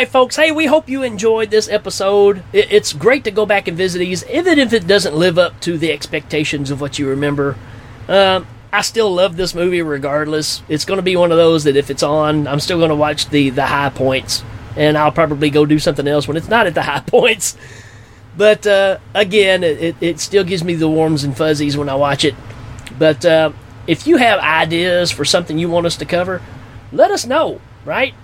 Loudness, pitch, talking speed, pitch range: -14 LUFS, 165 Hz, 220 wpm, 145-195 Hz